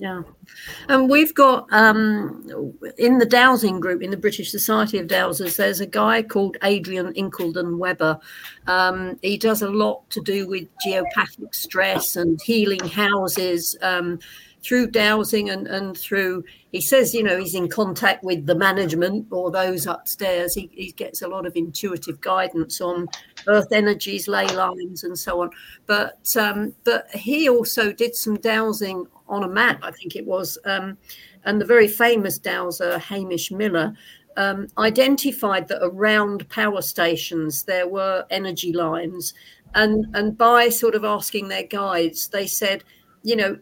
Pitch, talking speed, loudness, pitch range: 195 Hz, 160 wpm, -20 LUFS, 180-215 Hz